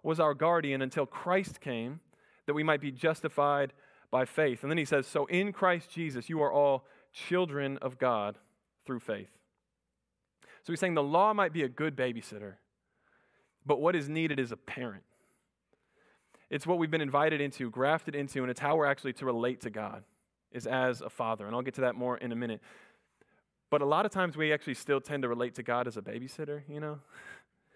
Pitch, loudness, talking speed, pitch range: 145 Hz, -32 LUFS, 205 wpm, 125-155 Hz